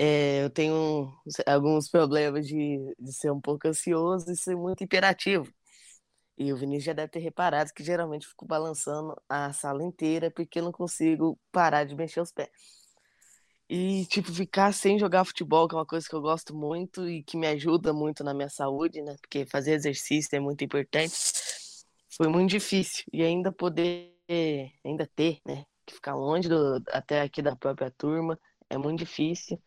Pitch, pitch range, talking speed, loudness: 160 Hz, 145-175 Hz, 175 wpm, -28 LUFS